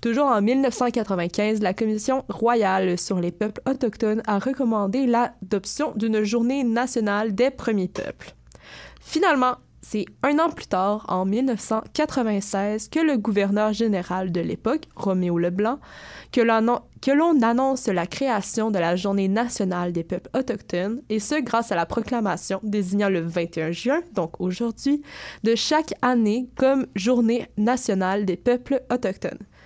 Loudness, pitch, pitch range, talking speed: -23 LUFS, 225 Hz, 195-250 Hz, 140 wpm